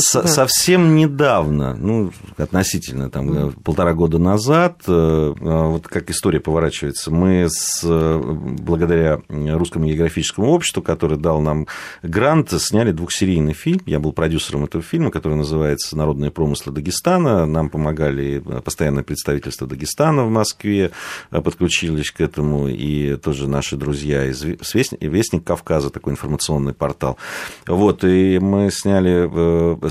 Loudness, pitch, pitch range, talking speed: -18 LUFS, 80 Hz, 75-95 Hz, 120 wpm